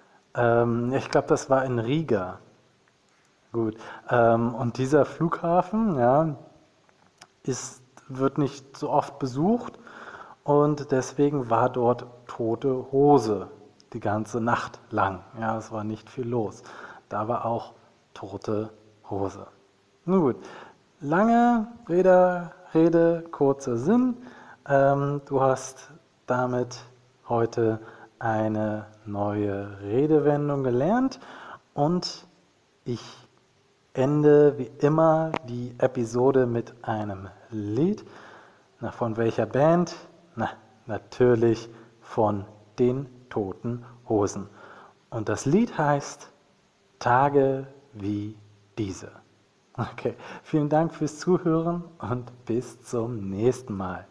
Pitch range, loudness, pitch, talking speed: 110-145 Hz, -25 LUFS, 125 Hz, 100 wpm